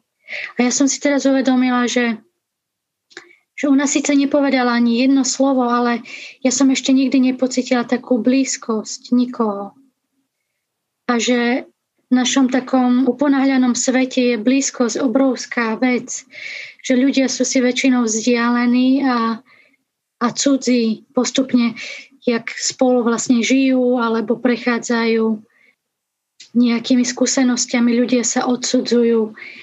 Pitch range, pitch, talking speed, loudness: 240-265 Hz, 250 Hz, 110 wpm, -17 LUFS